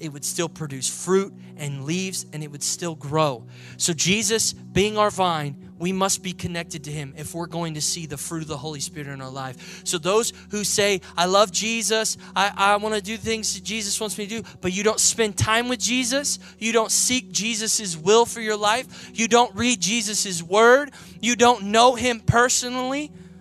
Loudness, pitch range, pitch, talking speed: -22 LUFS, 170-225 Hz, 195 Hz, 205 wpm